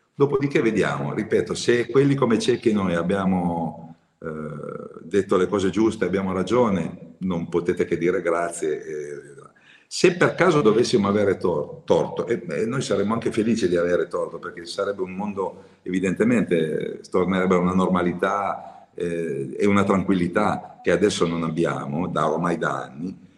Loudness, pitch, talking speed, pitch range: -23 LUFS, 95 Hz, 155 wpm, 85-135 Hz